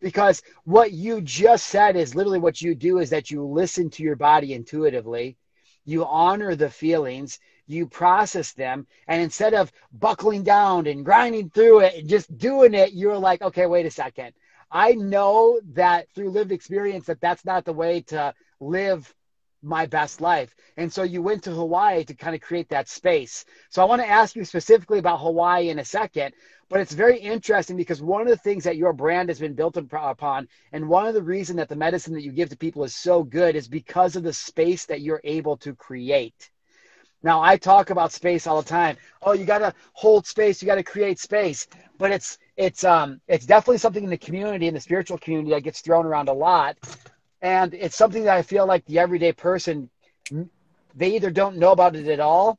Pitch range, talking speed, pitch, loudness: 155-195 Hz, 205 wpm, 175 Hz, -21 LUFS